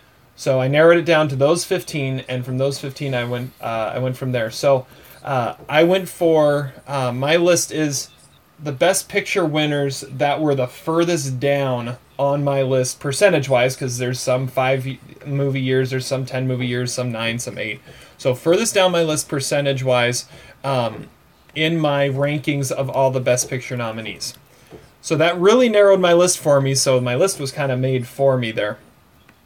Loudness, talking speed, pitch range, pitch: -19 LUFS, 185 wpm, 130-155 Hz, 135 Hz